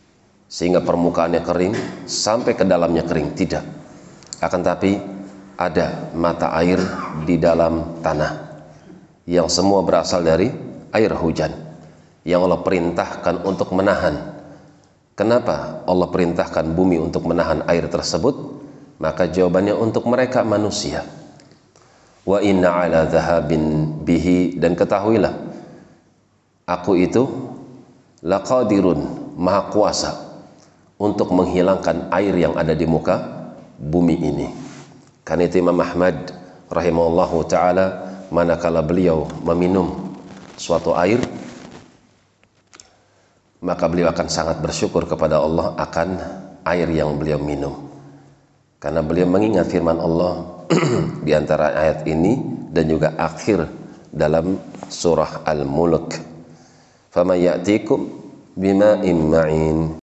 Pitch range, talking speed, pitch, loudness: 80-95 Hz, 100 wpm, 85 Hz, -19 LUFS